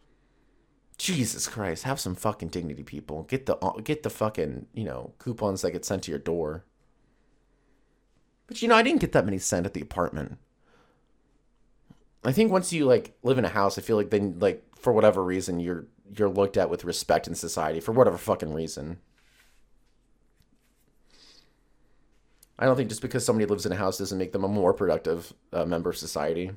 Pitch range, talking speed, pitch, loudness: 90-115 Hz, 185 wpm, 100 Hz, -27 LUFS